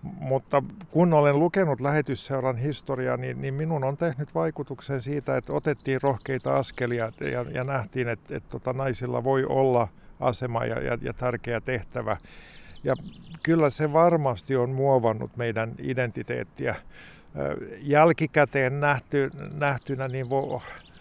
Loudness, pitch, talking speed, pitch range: -26 LUFS, 135 Hz, 110 wpm, 125-150 Hz